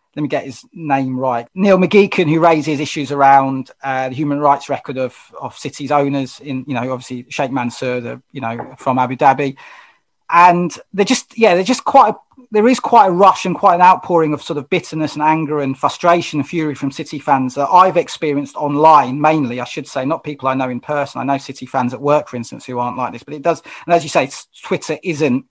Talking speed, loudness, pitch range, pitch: 235 wpm, -15 LUFS, 135-170 Hz, 145 Hz